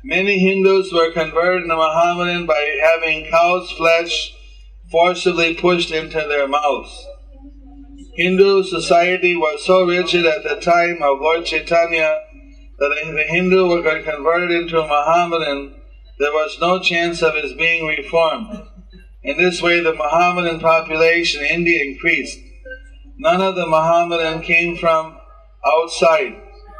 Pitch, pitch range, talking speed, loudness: 170 Hz, 160-185 Hz, 130 wpm, -16 LUFS